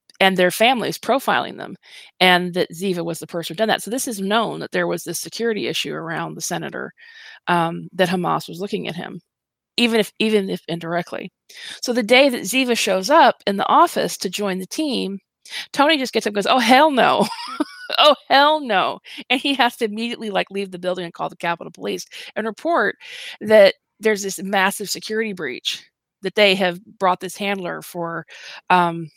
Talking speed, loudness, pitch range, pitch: 195 wpm, -19 LUFS, 180-245 Hz, 200 Hz